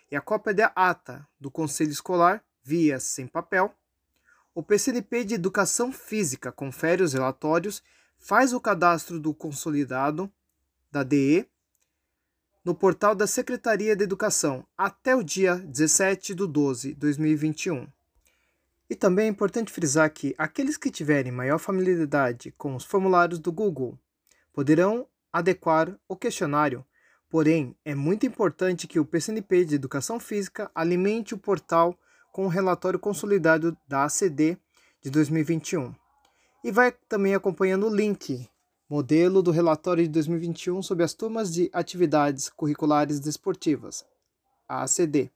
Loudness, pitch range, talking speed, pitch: -25 LUFS, 150-200 Hz, 135 wpm, 175 Hz